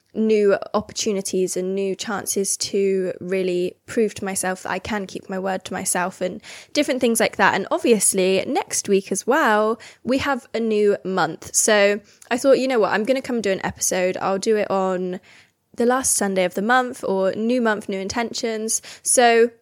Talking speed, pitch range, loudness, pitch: 195 wpm, 190-230 Hz, -21 LUFS, 205 Hz